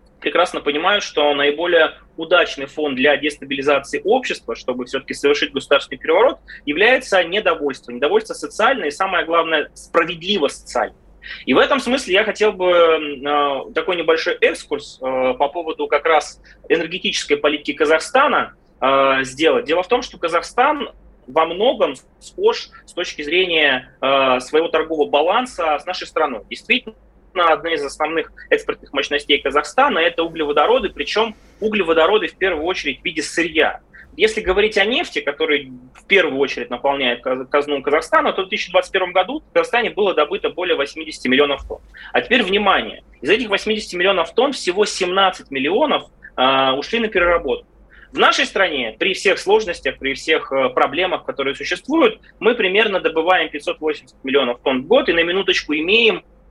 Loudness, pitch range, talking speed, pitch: -18 LUFS, 145-210 Hz, 145 wpm, 165 Hz